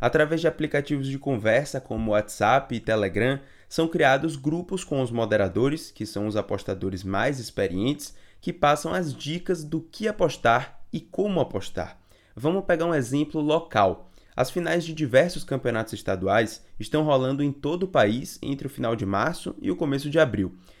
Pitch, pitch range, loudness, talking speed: 135 Hz, 110-155 Hz, -25 LUFS, 165 wpm